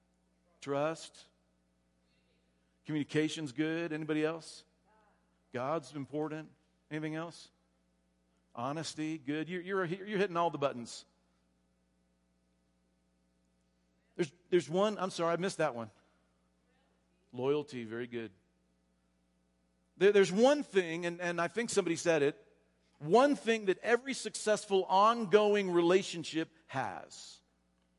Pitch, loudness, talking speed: 140 Hz, -33 LUFS, 105 wpm